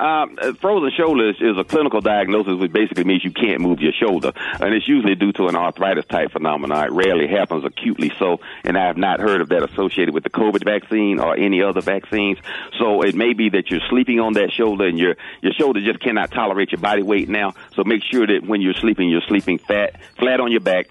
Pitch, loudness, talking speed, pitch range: 105 Hz, -18 LUFS, 230 wpm, 95-115 Hz